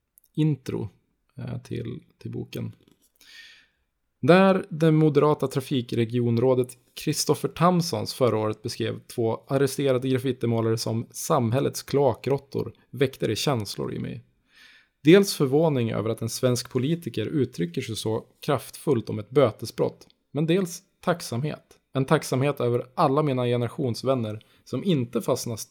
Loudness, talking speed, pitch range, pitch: -25 LUFS, 115 wpm, 115-150 Hz, 130 Hz